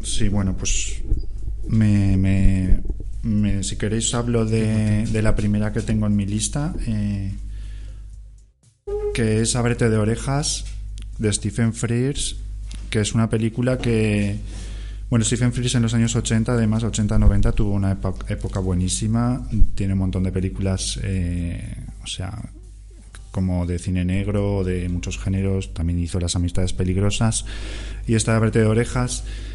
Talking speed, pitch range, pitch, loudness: 145 wpm, 95-115 Hz, 105 Hz, -22 LUFS